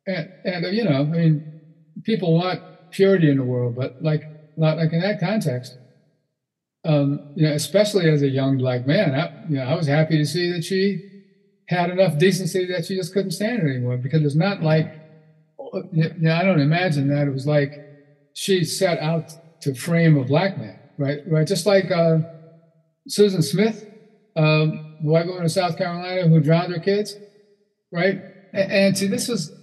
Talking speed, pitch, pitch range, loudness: 190 wpm, 165 Hz, 155-190 Hz, -21 LUFS